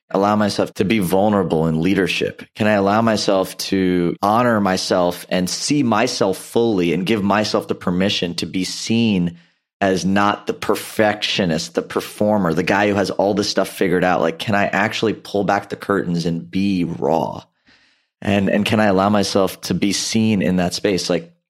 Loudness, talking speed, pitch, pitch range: -18 LUFS, 180 wpm, 95 Hz, 90-105 Hz